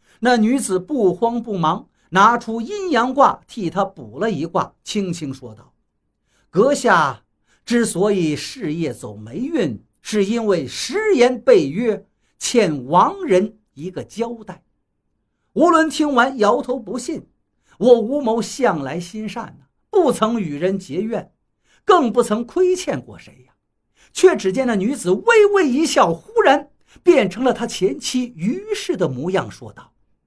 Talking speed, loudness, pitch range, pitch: 205 characters per minute, -18 LUFS, 185-265 Hz, 225 Hz